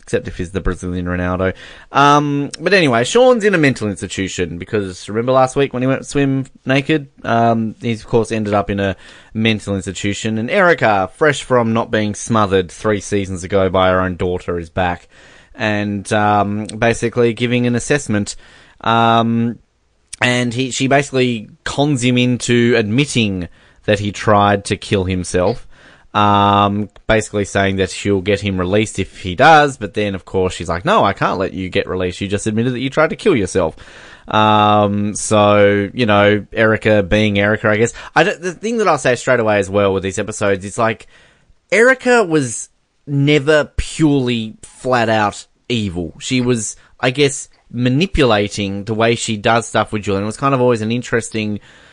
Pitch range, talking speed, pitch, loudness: 100-125 Hz, 180 wpm, 110 Hz, -16 LUFS